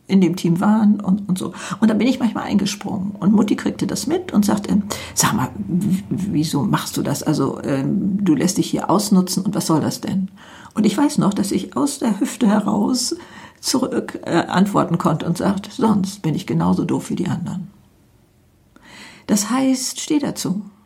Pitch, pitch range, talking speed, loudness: 195 Hz, 175-220 Hz, 195 wpm, -19 LUFS